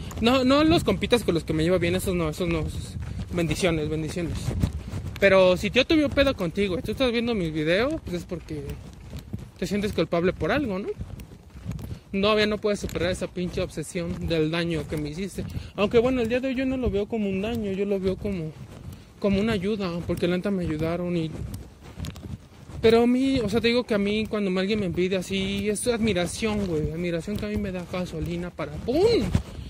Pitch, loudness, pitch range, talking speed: 185 Hz, -25 LUFS, 165-210 Hz, 205 wpm